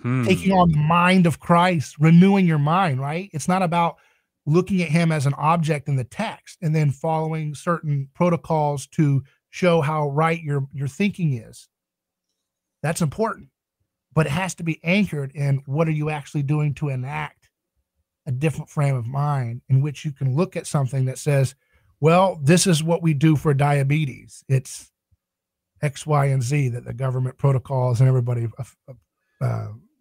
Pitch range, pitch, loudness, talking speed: 135-165 Hz, 150 Hz, -21 LUFS, 170 wpm